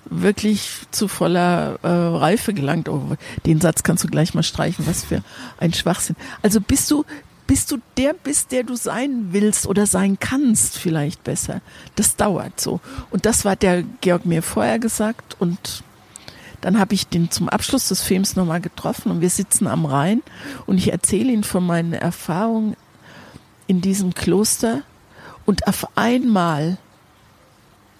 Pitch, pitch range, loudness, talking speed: 195 Hz, 170-220 Hz, -19 LUFS, 160 wpm